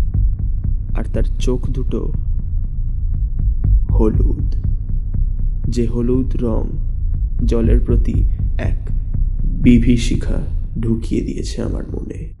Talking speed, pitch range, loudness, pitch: 80 wpm, 95-115 Hz, -20 LUFS, 100 Hz